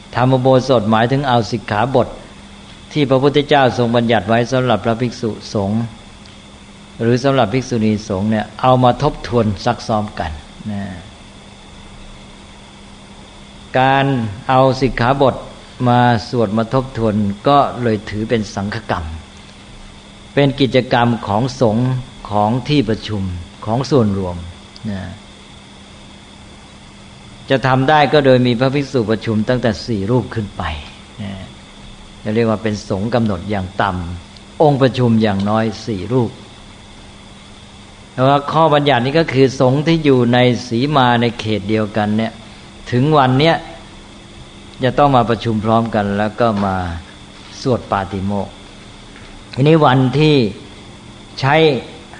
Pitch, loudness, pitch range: 110 Hz, -15 LUFS, 100-130 Hz